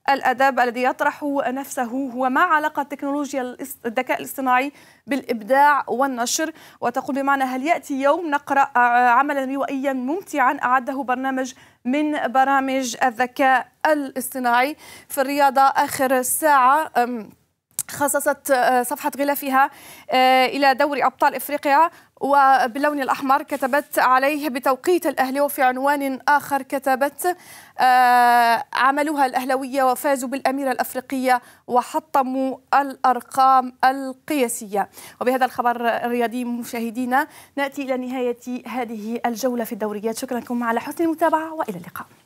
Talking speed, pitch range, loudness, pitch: 105 wpm, 250-285 Hz, -20 LUFS, 265 Hz